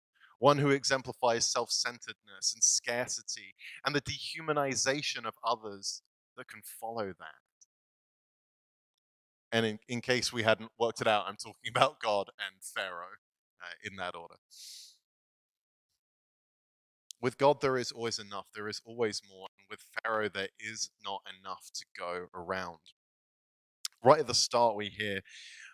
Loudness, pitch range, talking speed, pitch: -32 LUFS, 100-125 Hz, 140 wpm, 110 Hz